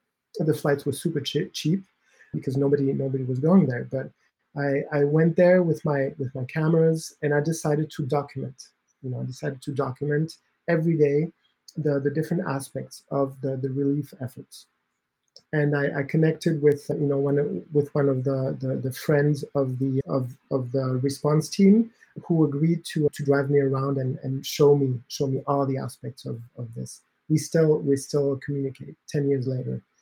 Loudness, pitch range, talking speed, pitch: -25 LUFS, 135-155 Hz, 185 wpm, 145 Hz